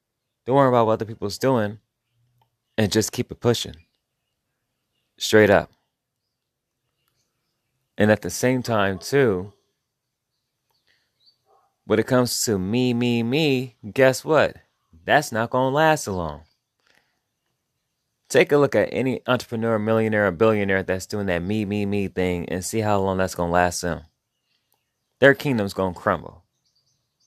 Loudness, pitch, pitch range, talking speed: -21 LUFS, 110 Hz, 100-125 Hz, 140 wpm